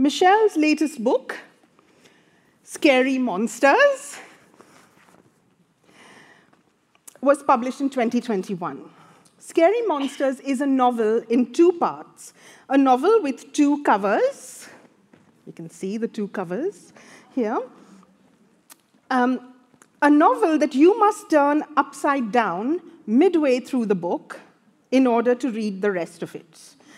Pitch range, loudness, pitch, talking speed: 230-305 Hz, -21 LUFS, 270 Hz, 110 wpm